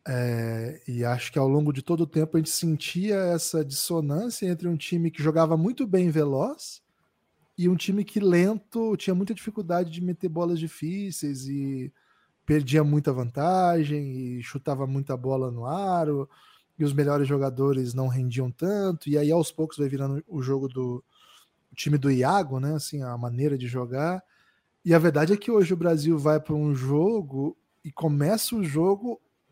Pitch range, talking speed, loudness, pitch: 135-175 Hz, 175 wpm, -26 LUFS, 155 Hz